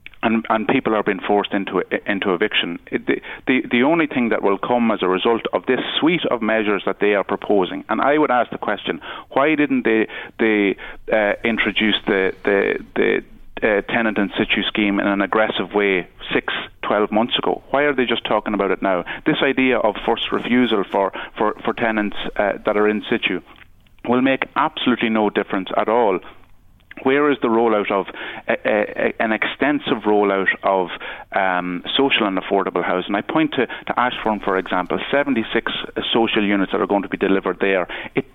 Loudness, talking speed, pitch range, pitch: -19 LUFS, 190 wpm, 100-120 Hz, 110 Hz